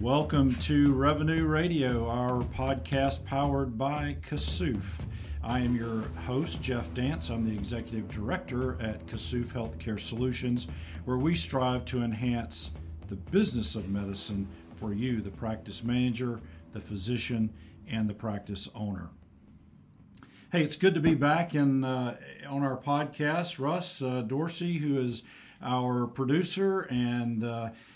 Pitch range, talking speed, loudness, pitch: 105-135 Hz, 135 wpm, -31 LUFS, 120 Hz